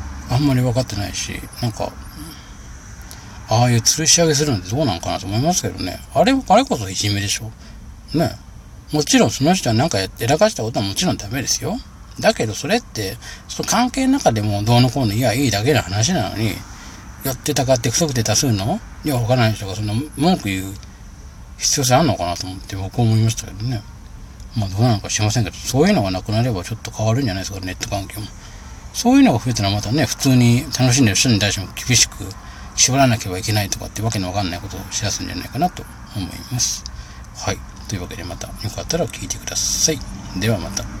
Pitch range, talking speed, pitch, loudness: 100-130 Hz, 450 characters per minute, 110 Hz, -18 LUFS